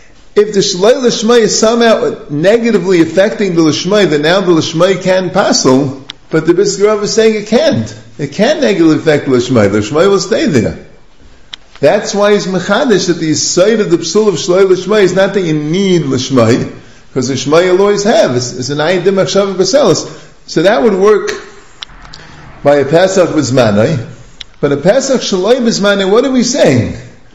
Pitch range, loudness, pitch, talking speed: 145-205 Hz, -10 LUFS, 185 Hz, 170 wpm